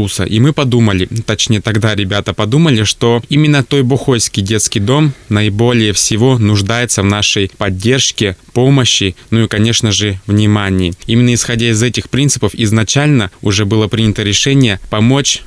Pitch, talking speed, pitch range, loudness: 110 Hz, 140 wpm, 105-125 Hz, -11 LUFS